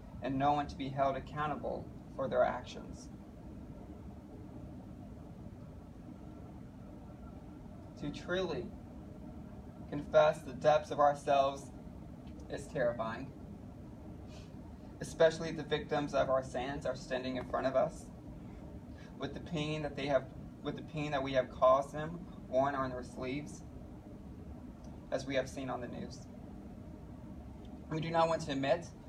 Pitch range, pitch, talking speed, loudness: 130-150 Hz, 145 Hz, 125 wpm, -35 LUFS